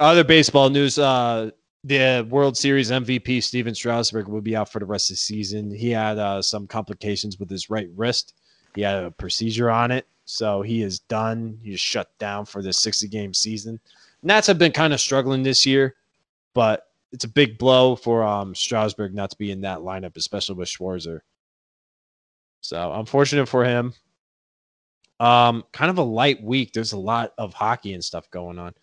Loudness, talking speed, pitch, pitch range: -21 LUFS, 185 wpm, 110 Hz, 100-130 Hz